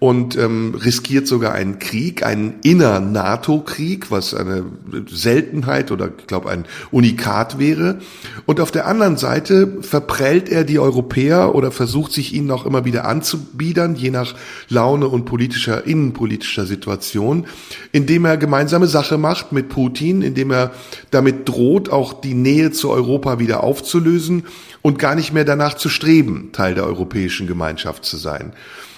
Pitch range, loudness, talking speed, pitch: 120-155 Hz, -17 LUFS, 145 wpm, 135 Hz